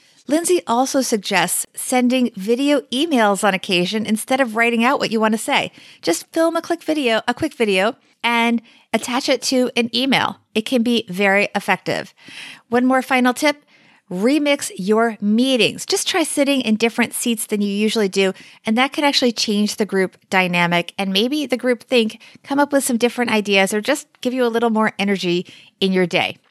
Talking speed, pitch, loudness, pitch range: 190 wpm, 235 Hz, -18 LUFS, 205-260 Hz